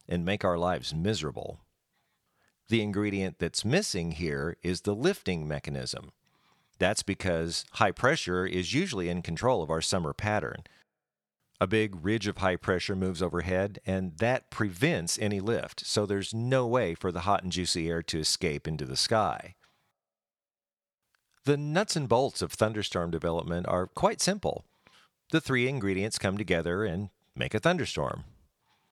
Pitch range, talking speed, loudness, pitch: 85-105 Hz, 150 wpm, -29 LUFS, 95 Hz